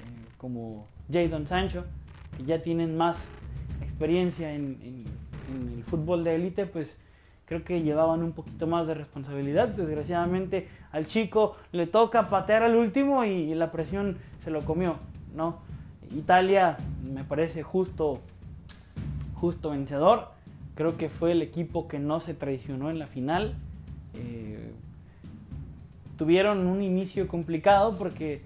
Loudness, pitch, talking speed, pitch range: -28 LUFS, 160 Hz, 135 wpm, 130-175 Hz